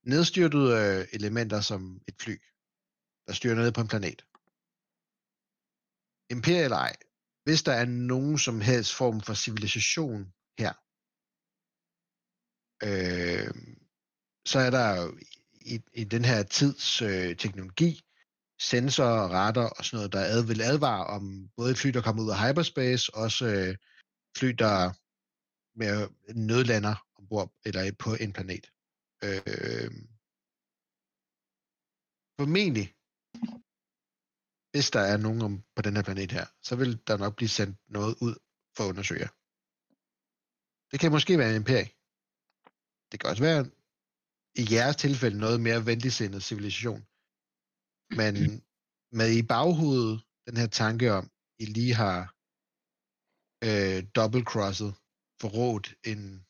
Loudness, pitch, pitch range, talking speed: -28 LUFS, 115 Hz, 105-130 Hz, 125 wpm